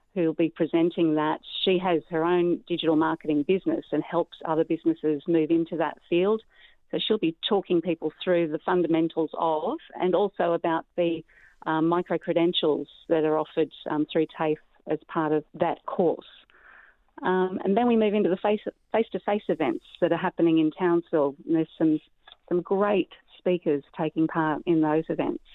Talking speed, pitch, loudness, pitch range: 170 wpm, 170 Hz, -26 LUFS, 160-180 Hz